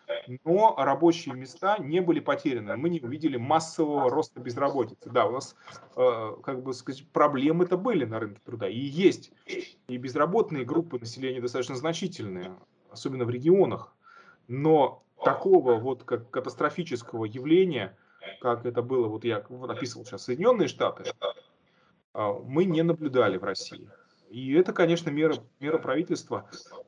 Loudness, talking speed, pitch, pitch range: -27 LUFS, 140 wpm, 140 Hz, 125-170 Hz